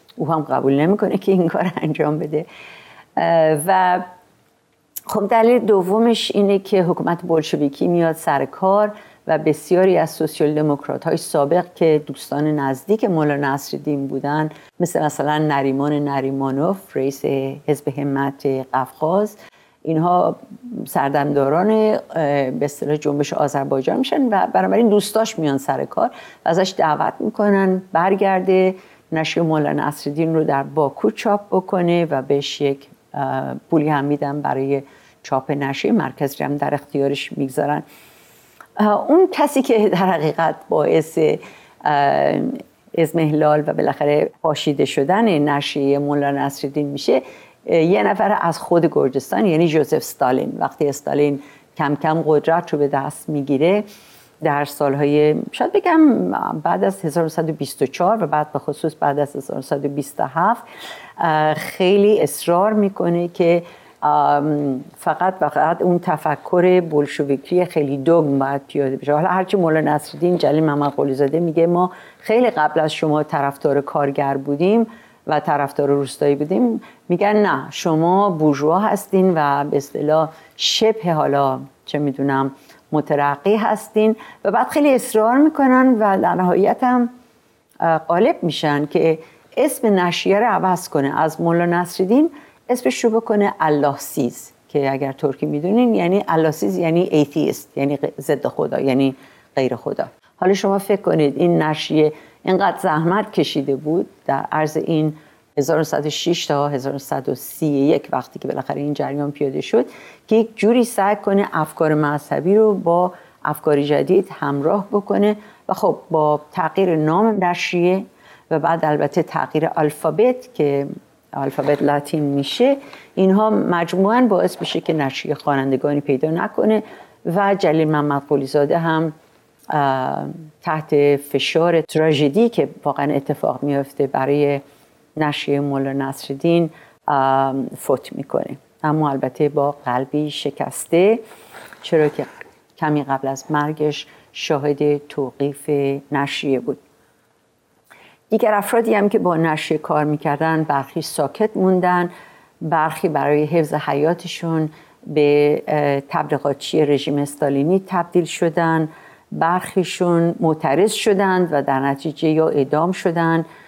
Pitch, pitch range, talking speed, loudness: 155 Hz, 145-185 Hz, 125 wpm, -18 LUFS